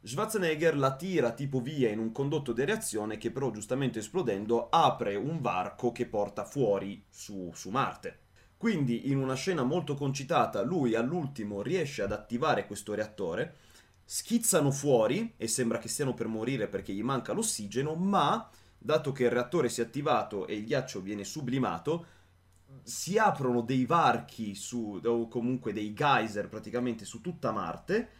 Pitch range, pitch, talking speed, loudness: 110-145 Hz, 125 Hz, 155 wpm, -31 LUFS